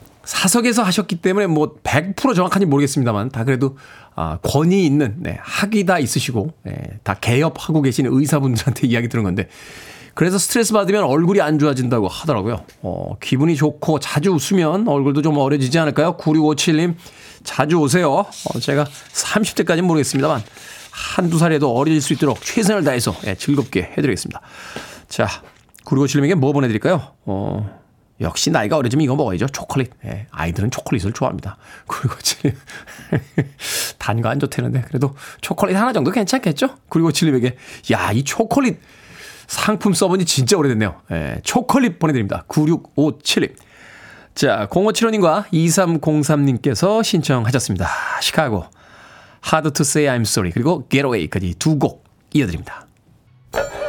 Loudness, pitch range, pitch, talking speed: -18 LUFS, 125-175 Hz, 145 Hz, 335 characters per minute